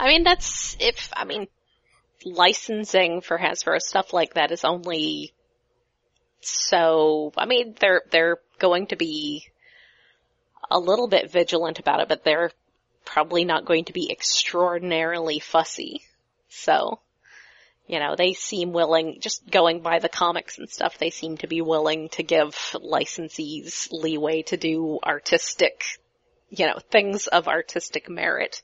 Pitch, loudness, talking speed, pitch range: 170 Hz, -23 LUFS, 140 wpm, 160-215 Hz